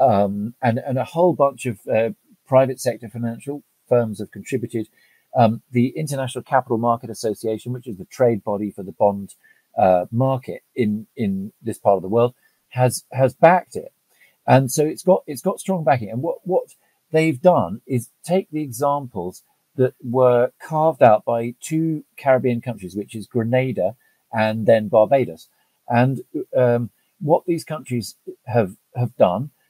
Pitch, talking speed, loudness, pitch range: 125 Hz, 160 wpm, -20 LUFS, 115-145 Hz